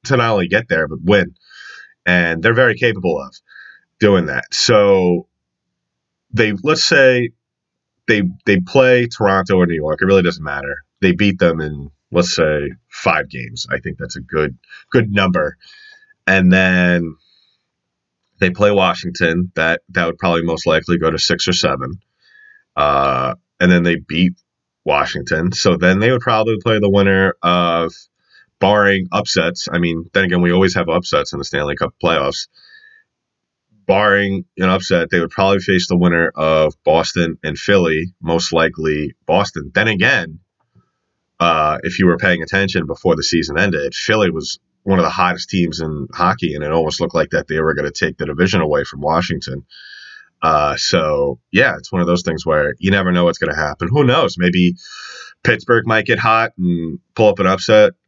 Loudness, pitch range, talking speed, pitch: -15 LUFS, 85-100 Hz, 175 wpm, 90 Hz